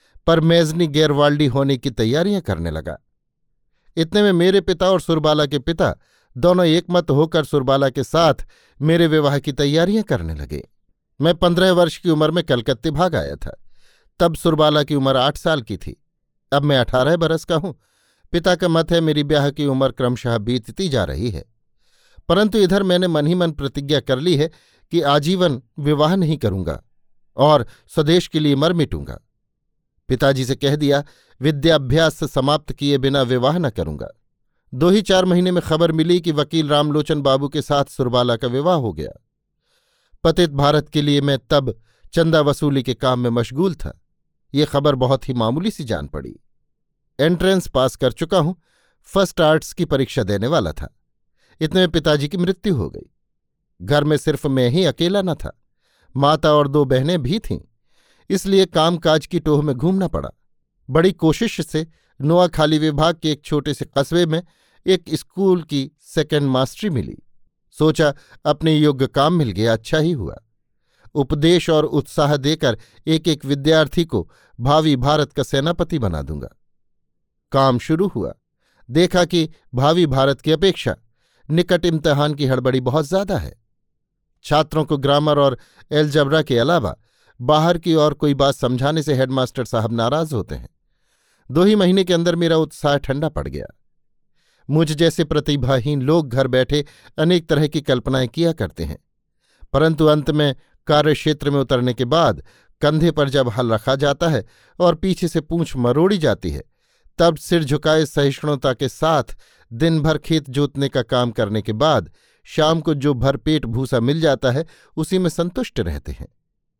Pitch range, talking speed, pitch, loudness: 135-165 Hz, 165 wpm, 150 Hz, -18 LUFS